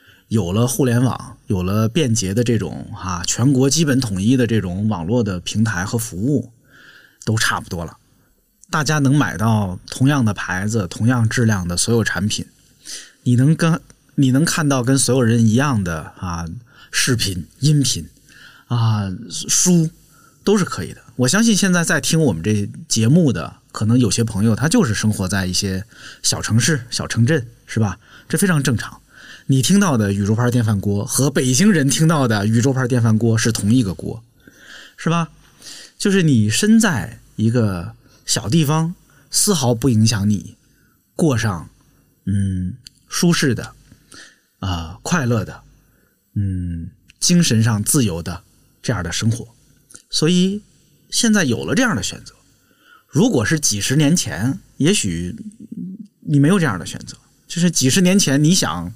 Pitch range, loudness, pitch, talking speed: 105-150 Hz, -18 LUFS, 120 Hz, 230 characters per minute